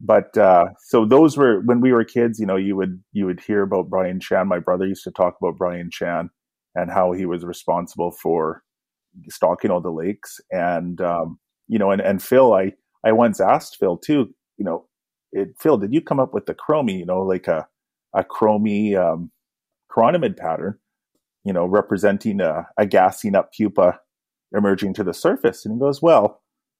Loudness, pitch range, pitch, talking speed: -20 LUFS, 90-110 Hz, 95 Hz, 195 wpm